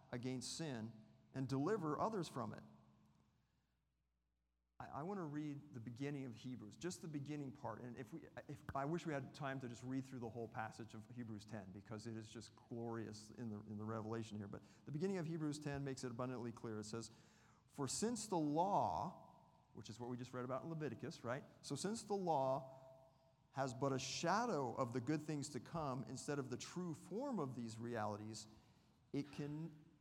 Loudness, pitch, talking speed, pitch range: -46 LUFS, 130 Hz, 200 wpm, 115-150 Hz